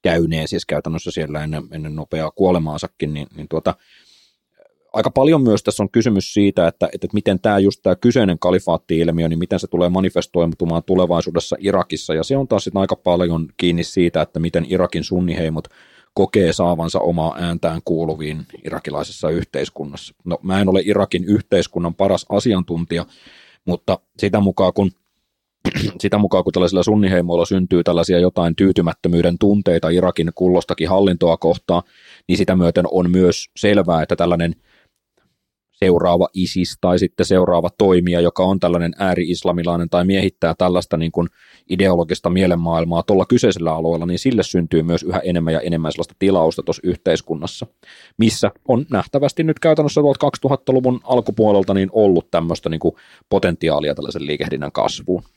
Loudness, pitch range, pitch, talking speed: -18 LUFS, 85-95 Hz, 90 Hz, 145 wpm